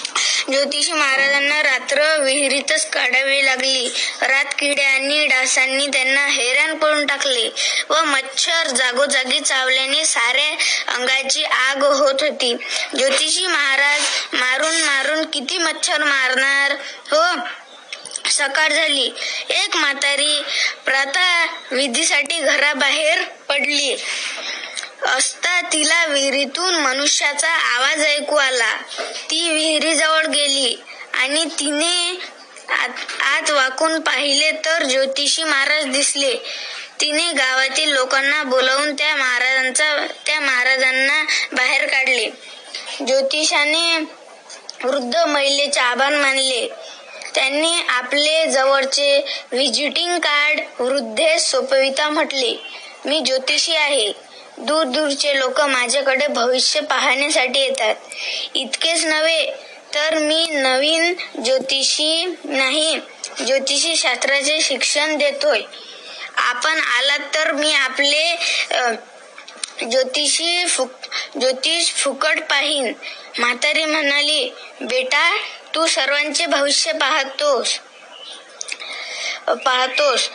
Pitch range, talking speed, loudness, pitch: 270-315 Hz, 85 wpm, -16 LUFS, 290 Hz